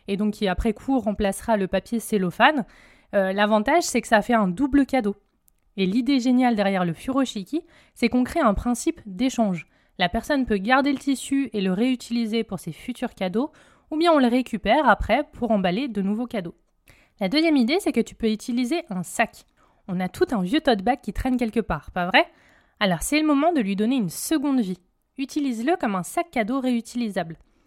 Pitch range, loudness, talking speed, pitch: 200-270 Hz, -23 LUFS, 200 wpm, 235 Hz